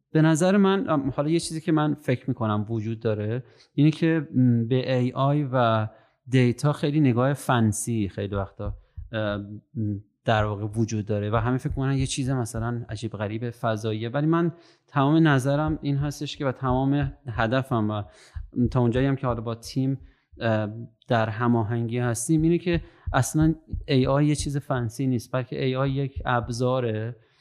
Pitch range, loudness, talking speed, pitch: 115-140 Hz, -25 LUFS, 155 wpm, 125 Hz